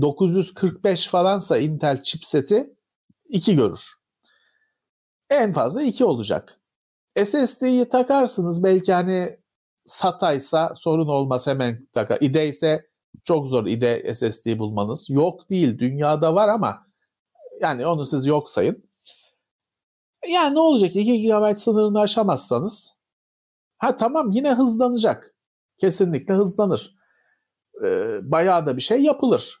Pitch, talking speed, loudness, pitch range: 190 Hz, 110 wpm, -21 LUFS, 150-245 Hz